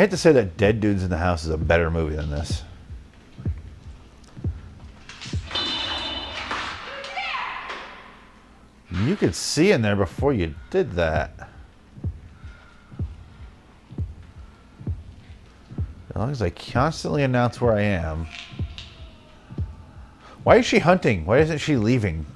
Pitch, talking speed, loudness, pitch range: 90 Hz, 115 wpm, -23 LUFS, 80-115 Hz